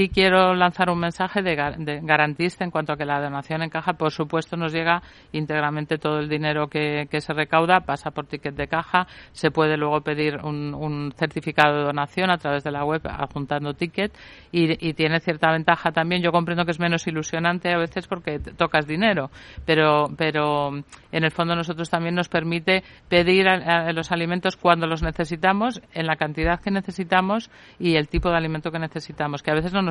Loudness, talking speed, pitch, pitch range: -23 LUFS, 200 wpm, 165 Hz, 150-175 Hz